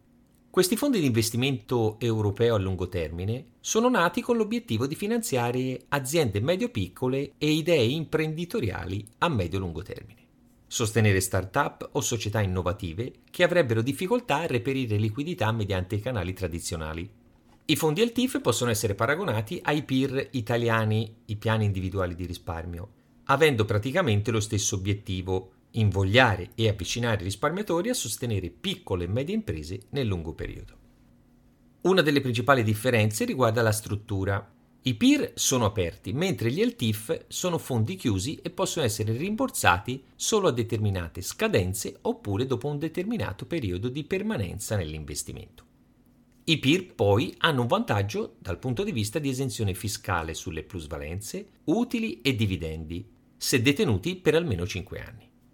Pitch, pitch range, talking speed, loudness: 115 Hz, 100-140 Hz, 135 wpm, -27 LUFS